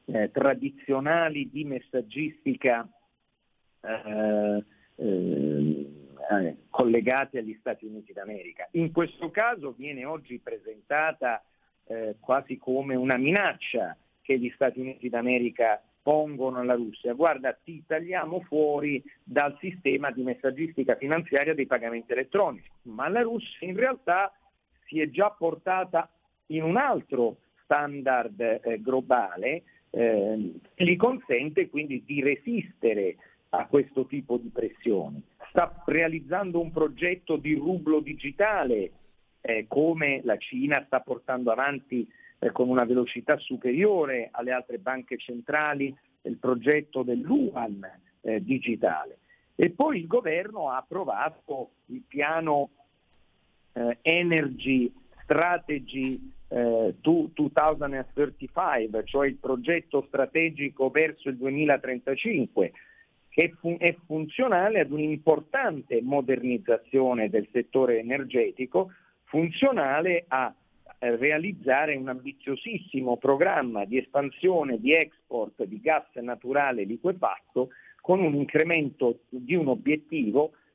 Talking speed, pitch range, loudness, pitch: 110 wpm, 125-165 Hz, -27 LUFS, 140 Hz